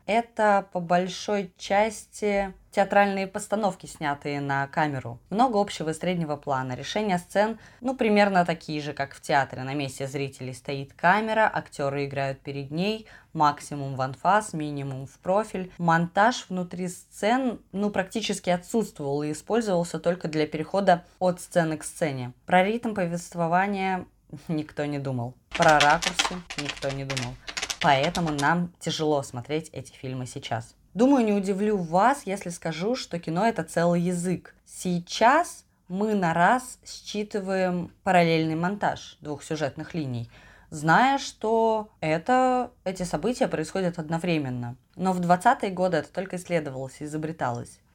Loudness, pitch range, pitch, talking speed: -26 LUFS, 145-200 Hz, 175 Hz, 135 wpm